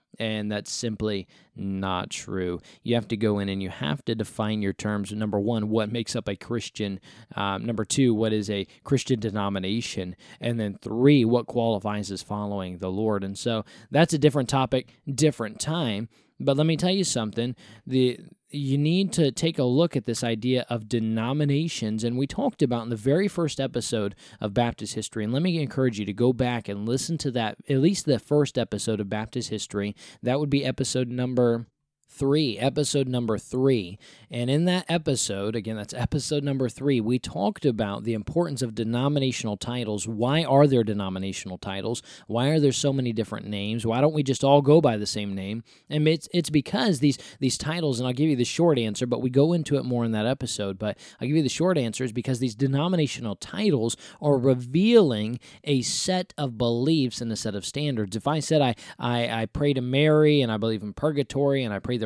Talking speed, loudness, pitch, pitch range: 205 wpm, -25 LUFS, 120 Hz, 110-145 Hz